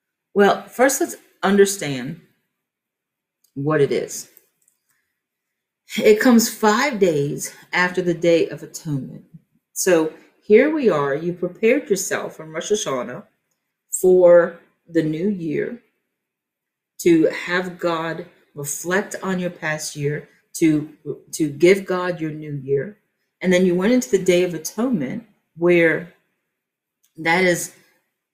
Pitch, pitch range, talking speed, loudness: 180 Hz, 160-210 Hz, 120 wpm, -19 LUFS